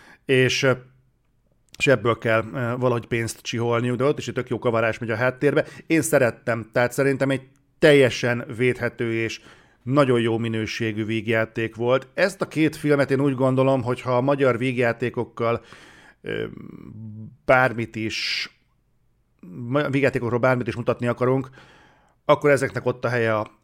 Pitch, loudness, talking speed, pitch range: 125 Hz, -22 LUFS, 140 wpm, 115-135 Hz